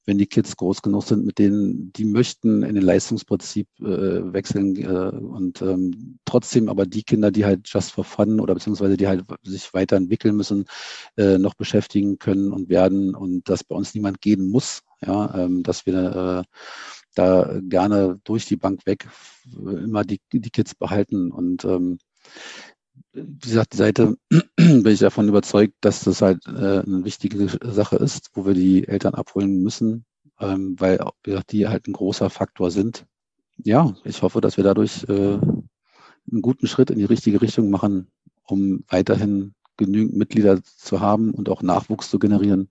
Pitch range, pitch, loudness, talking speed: 95-105 Hz, 100 Hz, -20 LUFS, 170 wpm